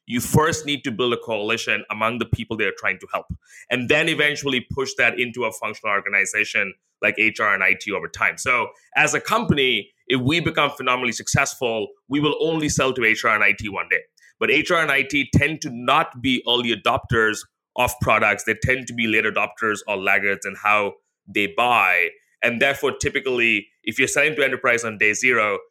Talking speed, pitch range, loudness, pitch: 195 wpm, 110-150 Hz, -20 LUFS, 130 Hz